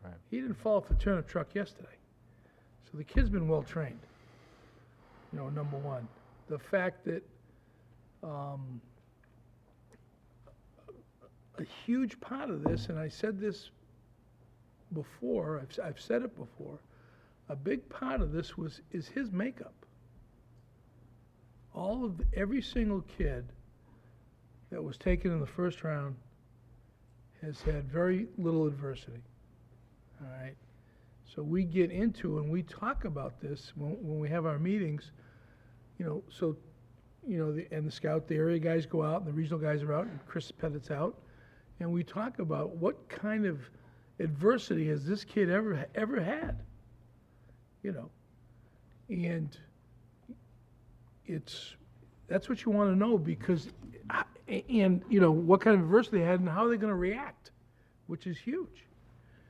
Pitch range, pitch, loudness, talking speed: 120-180 Hz, 150 Hz, -33 LUFS, 150 wpm